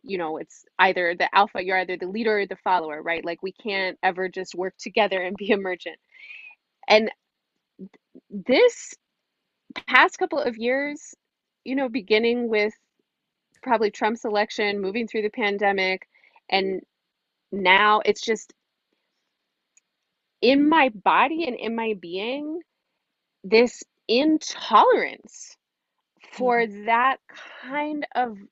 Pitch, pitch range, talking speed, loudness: 215 Hz, 190-260 Hz, 120 wpm, -22 LUFS